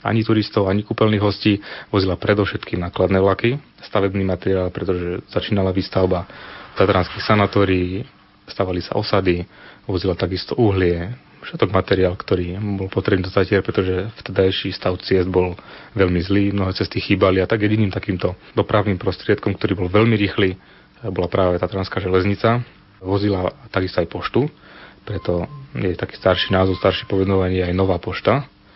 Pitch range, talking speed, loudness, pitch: 95-105 Hz, 140 wpm, -20 LUFS, 95 Hz